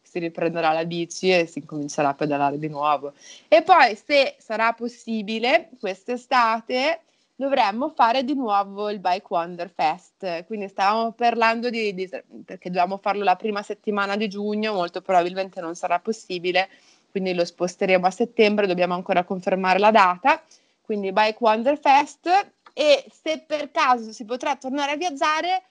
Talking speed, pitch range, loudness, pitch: 155 wpm, 180-255 Hz, -22 LUFS, 210 Hz